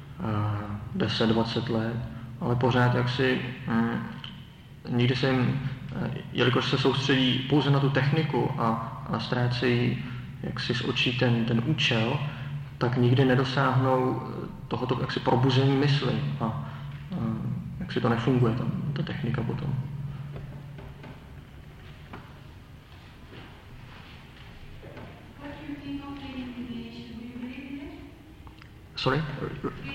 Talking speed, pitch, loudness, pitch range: 90 wpm, 130 Hz, -27 LUFS, 120-140 Hz